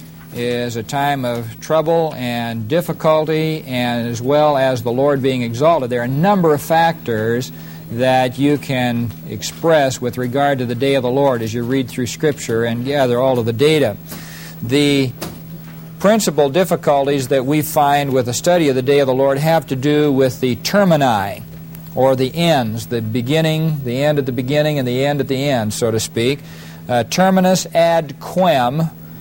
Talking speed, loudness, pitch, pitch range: 180 wpm, -16 LUFS, 135 Hz, 120-155 Hz